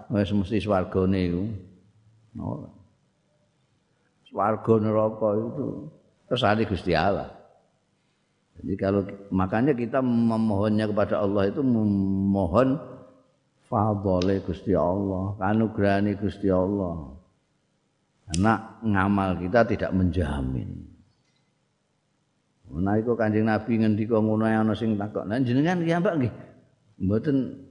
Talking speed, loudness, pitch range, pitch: 95 wpm, -25 LUFS, 95-110 Hz, 105 Hz